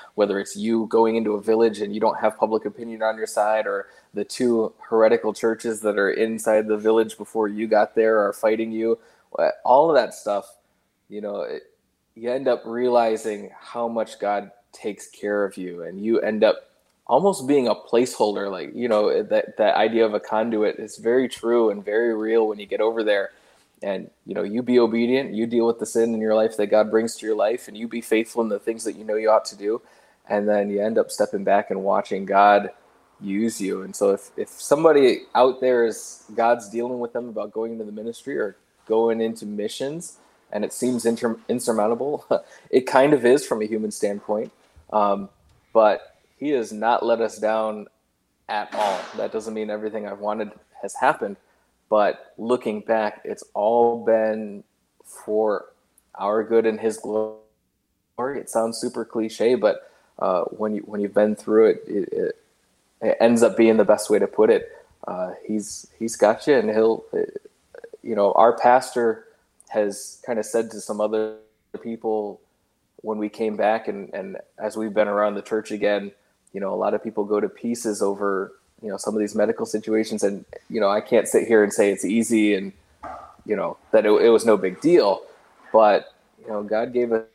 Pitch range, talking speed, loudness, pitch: 105-115 Hz, 200 wpm, -22 LUFS, 110 Hz